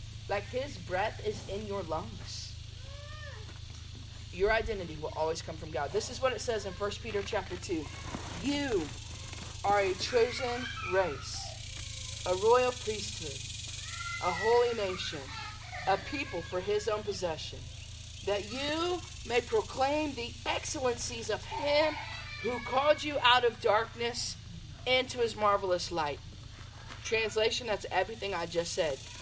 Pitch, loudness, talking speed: 190 Hz, -32 LUFS, 135 wpm